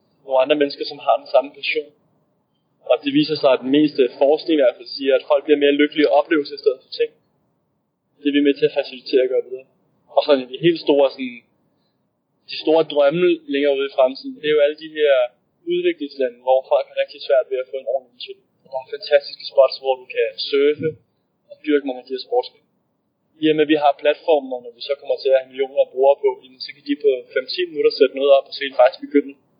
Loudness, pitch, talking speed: -19 LUFS, 150 Hz, 245 wpm